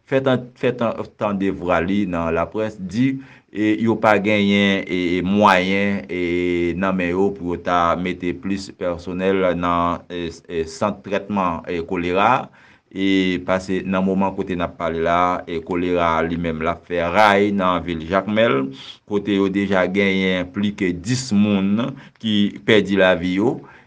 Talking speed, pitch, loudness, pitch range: 155 wpm, 95 Hz, -20 LUFS, 90-100 Hz